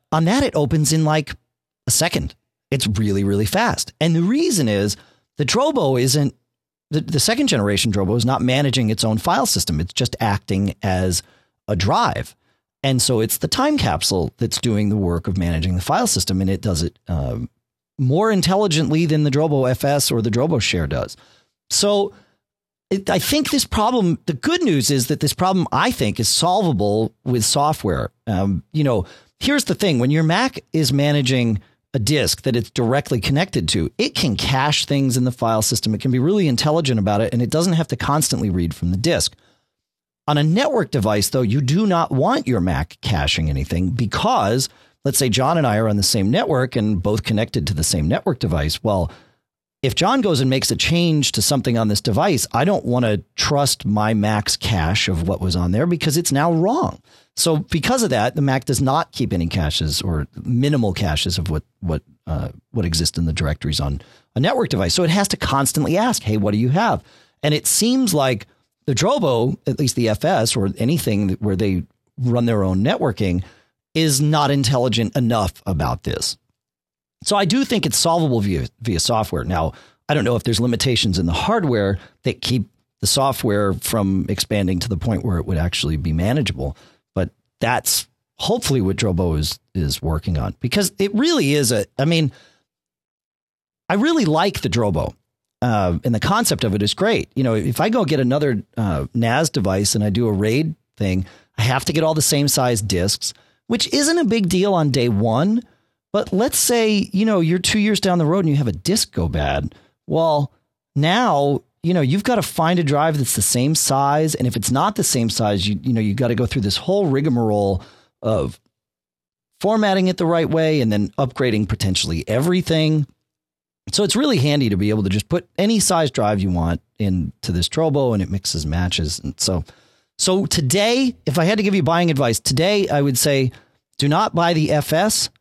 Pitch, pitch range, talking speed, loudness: 125 Hz, 100-155 Hz, 200 wpm, -19 LUFS